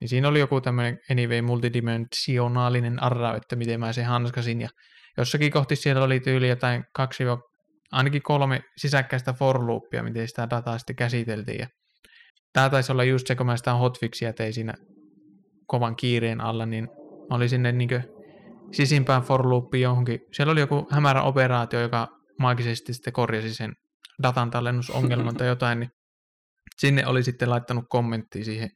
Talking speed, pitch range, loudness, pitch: 160 wpm, 115-130 Hz, -25 LUFS, 125 Hz